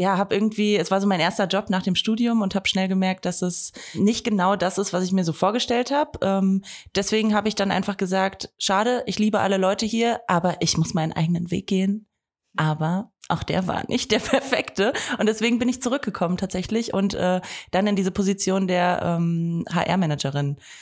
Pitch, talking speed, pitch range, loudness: 195 Hz, 200 wpm, 180-215 Hz, -22 LUFS